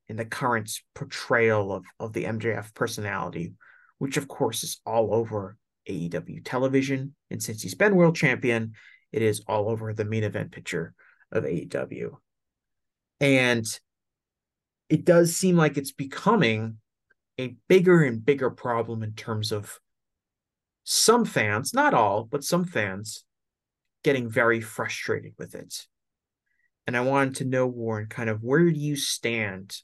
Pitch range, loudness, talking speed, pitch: 110-140 Hz, -25 LUFS, 145 wpm, 115 Hz